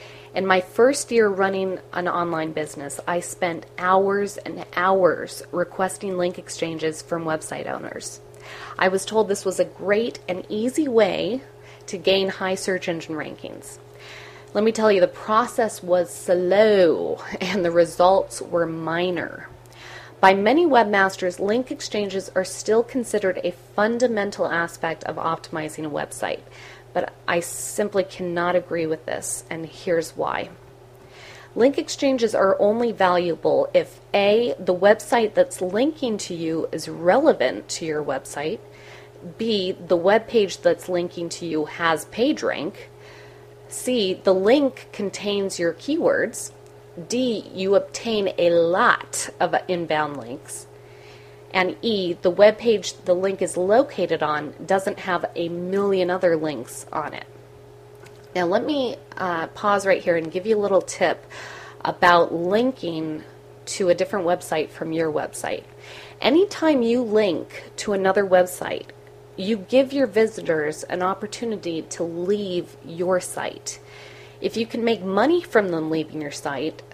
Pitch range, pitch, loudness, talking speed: 160-205 Hz, 180 Hz, -22 LUFS, 140 wpm